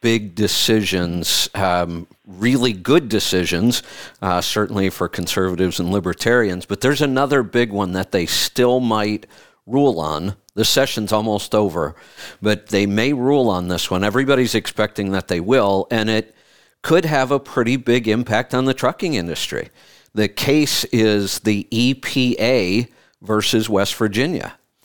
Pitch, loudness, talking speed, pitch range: 110 Hz, -18 LUFS, 145 wpm, 95-125 Hz